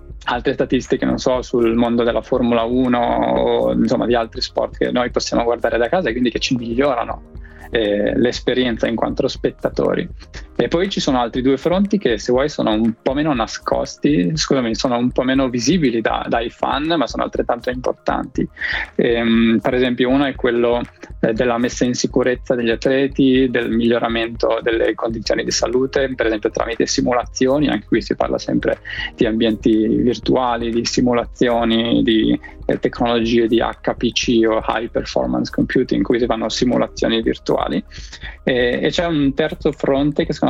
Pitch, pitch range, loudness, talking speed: 120 Hz, 115-130 Hz, -18 LUFS, 165 wpm